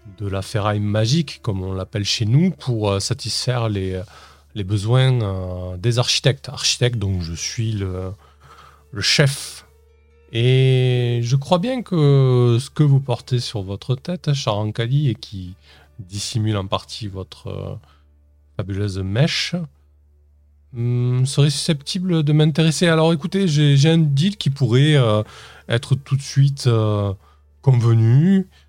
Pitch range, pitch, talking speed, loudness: 95-140 Hz, 115 Hz, 130 wpm, -19 LUFS